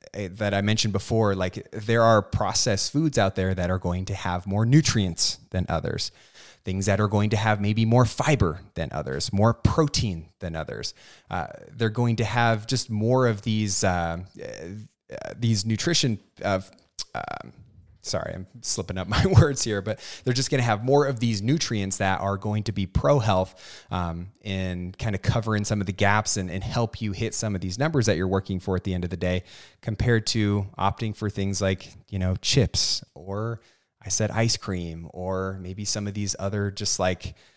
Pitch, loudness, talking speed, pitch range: 105 Hz, -25 LUFS, 200 wpm, 95-115 Hz